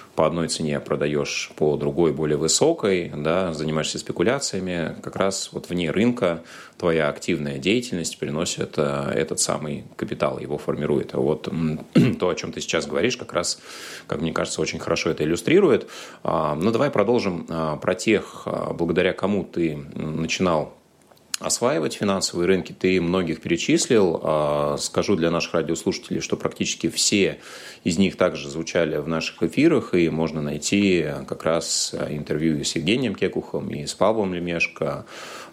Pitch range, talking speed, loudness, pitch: 75-90 Hz, 140 wpm, -23 LUFS, 80 Hz